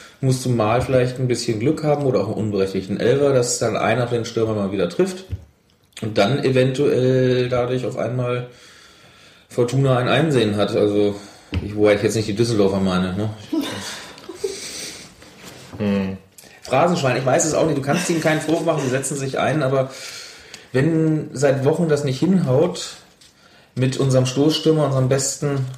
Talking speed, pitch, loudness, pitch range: 160 wpm, 130 Hz, -20 LUFS, 110-145 Hz